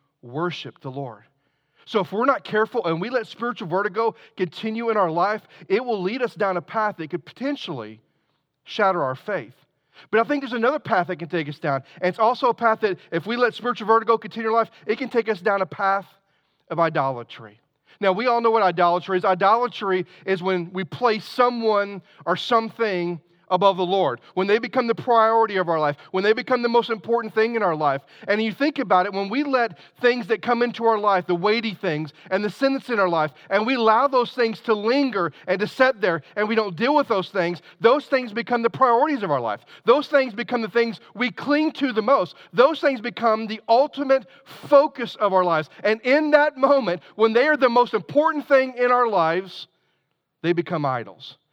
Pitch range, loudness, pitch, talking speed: 175-240 Hz, -22 LUFS, 210 Hz, 215 wpm